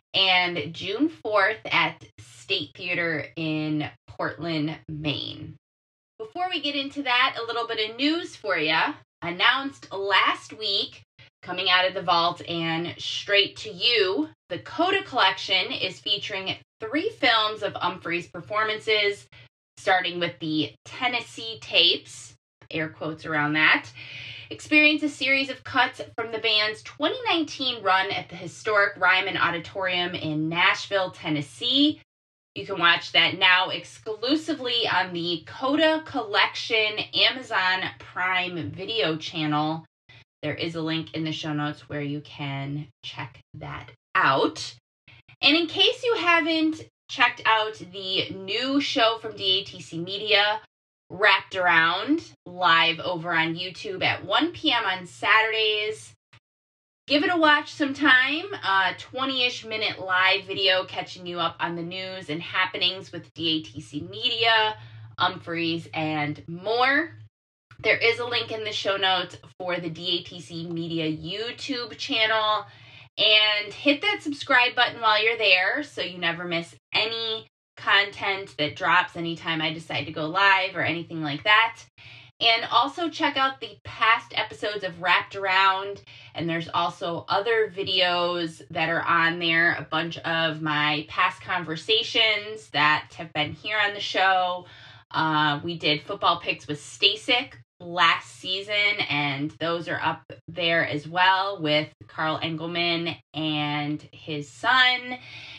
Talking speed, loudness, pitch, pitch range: 135 wpm, -23 LUFS, 180 Hz, 155-220 Hz